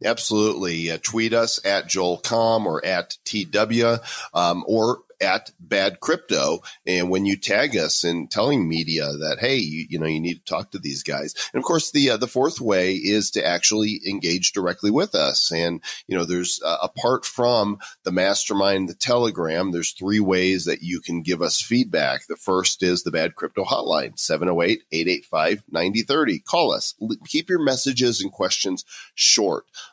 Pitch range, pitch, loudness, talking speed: 85-115 Hz, 95 Hz, -22 LUFS, 170 wpm